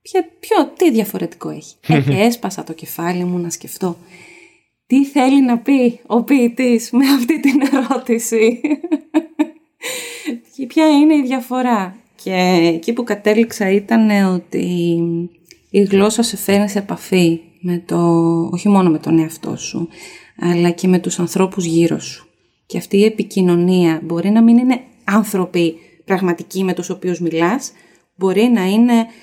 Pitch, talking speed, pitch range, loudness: 205 Hz, 145 wpm, 175-255 Hz, -16 LUFS